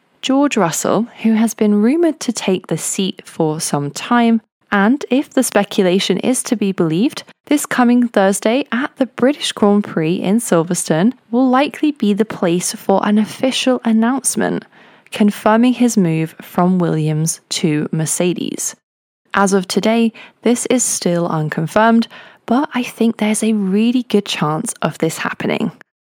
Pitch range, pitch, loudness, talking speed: 180-245 Hz, 215 Hz, -16 LUFS, 150 wpm